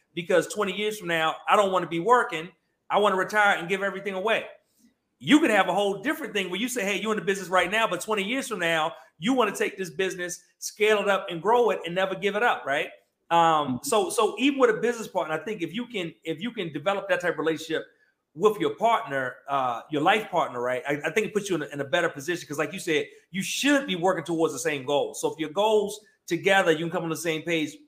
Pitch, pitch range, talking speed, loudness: 190 Hz, 165-215 Hz, 265 wpm, -25 LUFS